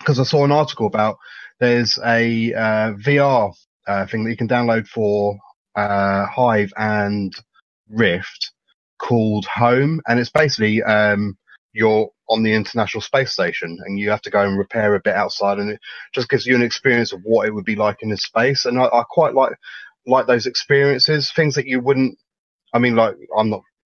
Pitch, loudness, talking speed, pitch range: 110 Hz, -18 LUFS, 190 wpm, 105-125 Hz